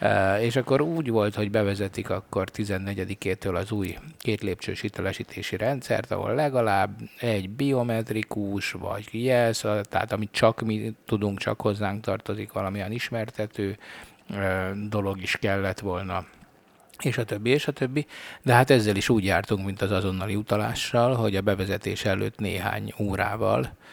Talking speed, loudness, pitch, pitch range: 140 wpm, -26 LUFS, 105 Hz, 95-115 Hz